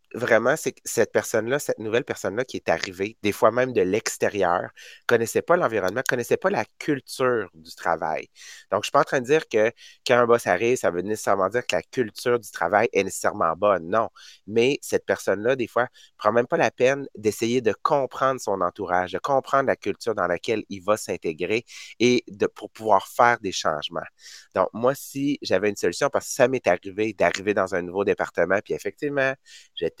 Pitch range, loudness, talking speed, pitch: 100-130 Hz, -24 LUFS, 205 wpm, 115 Hz